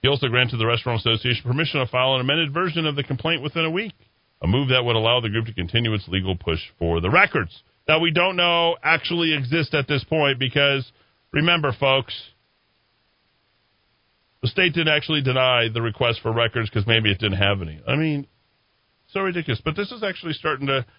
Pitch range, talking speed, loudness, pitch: 115-155 Hz, 200 wpm, -21 LUFS, 130 Hz